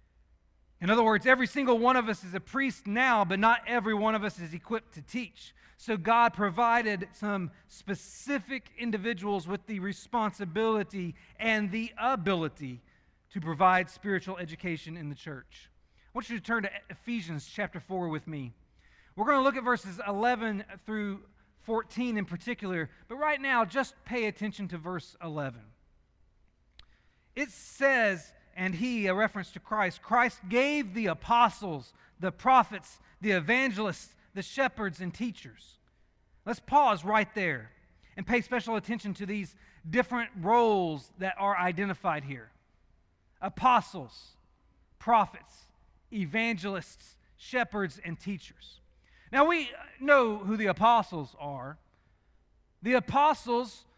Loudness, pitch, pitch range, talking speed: -29 LUFS, 200 Hz, 170-235 Hz, 135 wpm